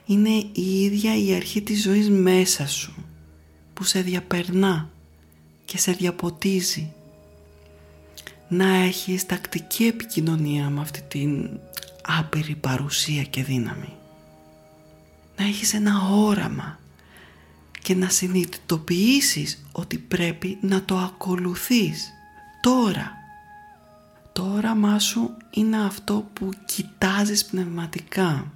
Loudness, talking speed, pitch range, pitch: -23 LUFS, 95 wpm, 140-205 Hz, 185 Hz